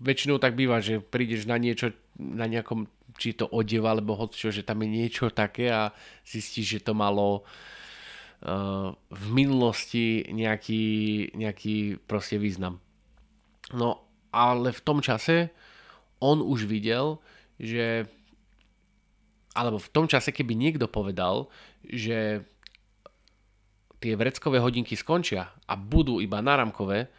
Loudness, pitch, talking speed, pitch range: -28 LUFS, 110 Hz, 125 wpm, 105-120 Hz